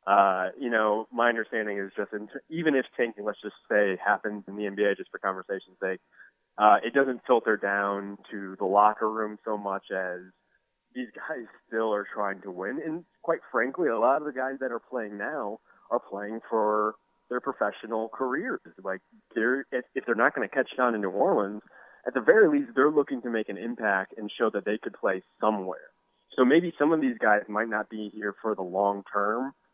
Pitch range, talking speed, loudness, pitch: 105-130 Hz, 210 wpm, -28 LUFS, 110 Hz